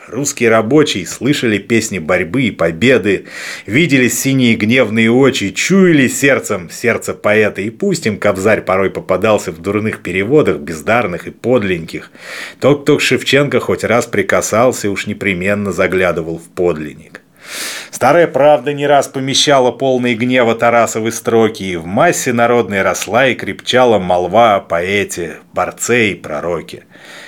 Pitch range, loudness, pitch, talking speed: 100-135 Hz, -13 LUFS, 115 Hz, 135 wpm